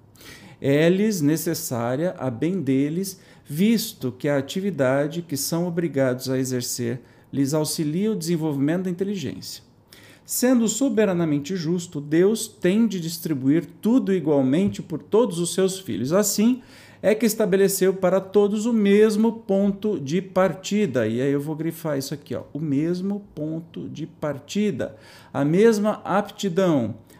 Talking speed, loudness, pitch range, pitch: 135 wpm, -23 LUFS, 145-200 Hz, 175 Hz